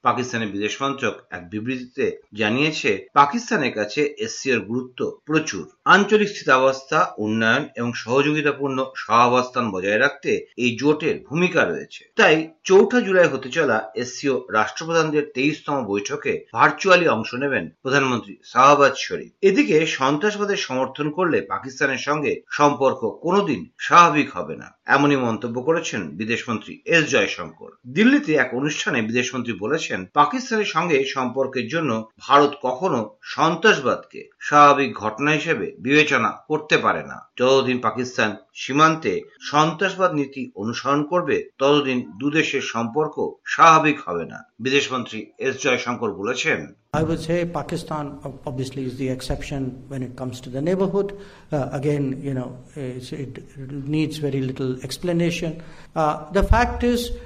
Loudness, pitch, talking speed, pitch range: -20 LUFS, 145 Hz, 80 wpm, 130-170 Hz